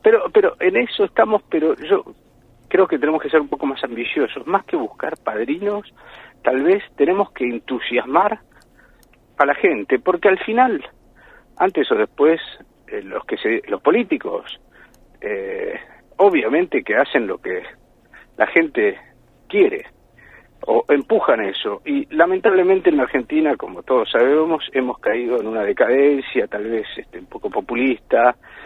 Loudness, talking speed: -19 LUFS, 145 wpm